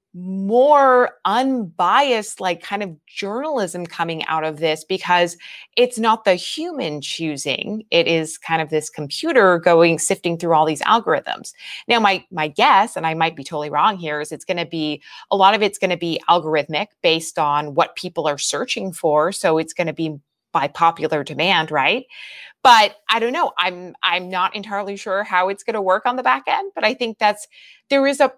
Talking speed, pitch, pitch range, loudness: 195 wpm, 180 Hz, 160-210 Hz, -18 LUFS